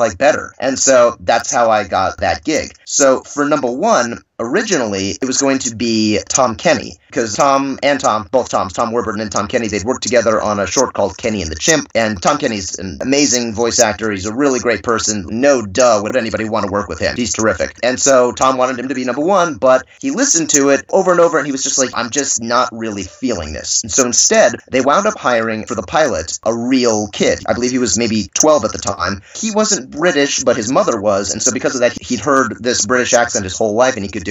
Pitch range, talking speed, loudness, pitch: 110-135 Hz, 245 wpm, -14 LUFS, 120 Hz